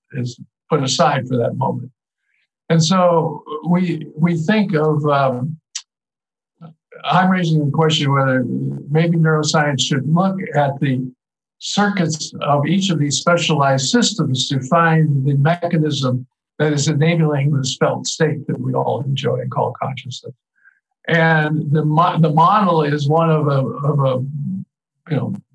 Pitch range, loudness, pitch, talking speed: 140-165 Hz, -17 LUFS, 155 Hz, 145 wpm